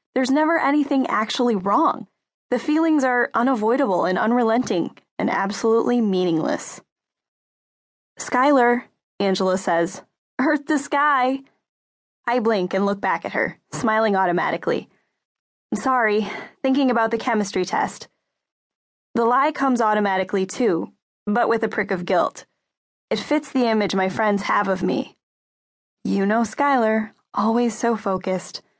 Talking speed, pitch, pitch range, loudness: 130 wpm, 225 Hz, 200-260 Hz, -21 LUFS